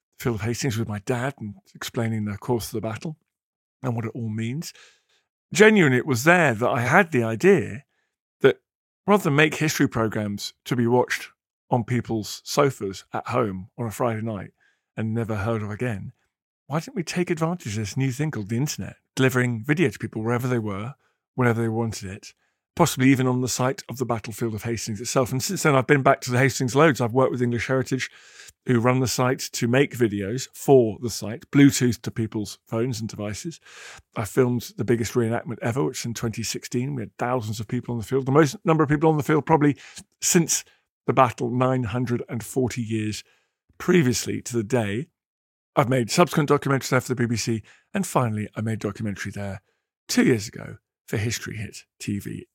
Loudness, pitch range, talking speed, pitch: -23 LUFS, 115-135 Hz, 195 wpm, 125 Hz